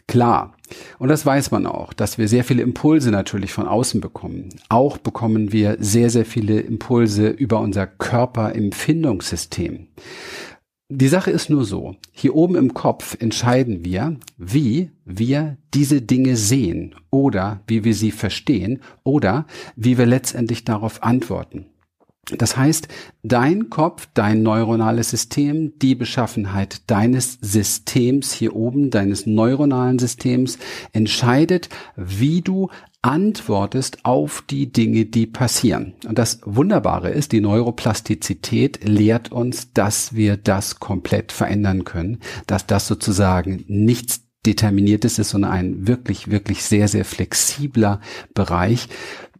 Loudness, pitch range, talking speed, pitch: -19 LUFS, 105-130 Hz, 130 wpm, 115 Hz